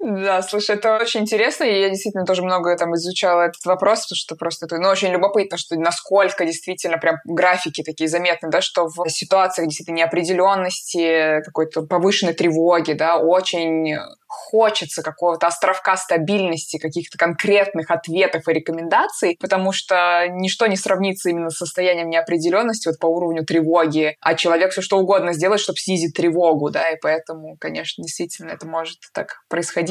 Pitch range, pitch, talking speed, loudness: 165-190 Hz, 175 Hz, 160 wpm, -19 LUFS